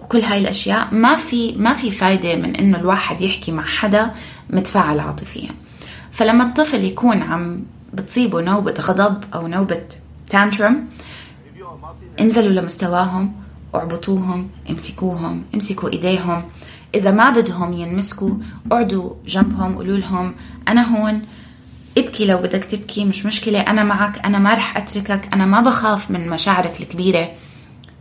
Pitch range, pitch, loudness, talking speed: 185-220 Hz, 200 Hz, -17 LUFS, 130 wpm